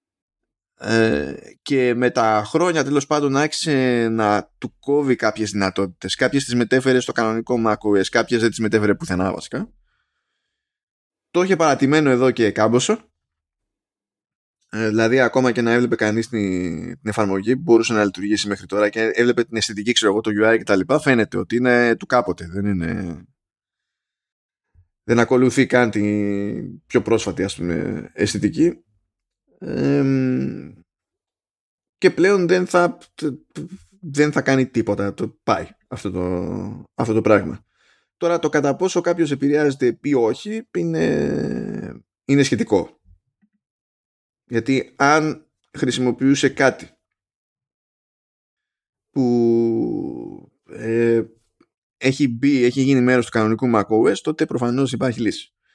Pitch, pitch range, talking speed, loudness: 120 Hz, 105-140 Hz, 125 wpm, -19 LUFS